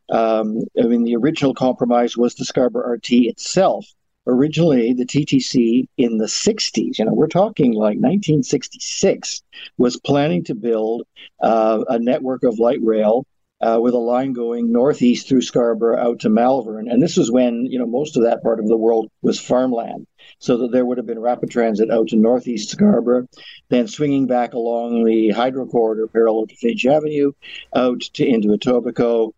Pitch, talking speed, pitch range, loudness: 120 Hz, 170 wpm, 115-125 Hz, -18 LUFS